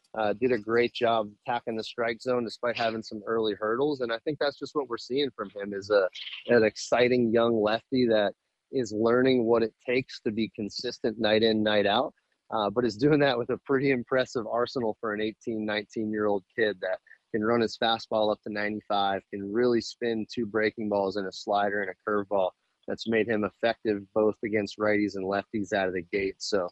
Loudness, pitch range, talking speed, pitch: -28 LUFS, 105-120 Hz, 210 wpm, 110 Hz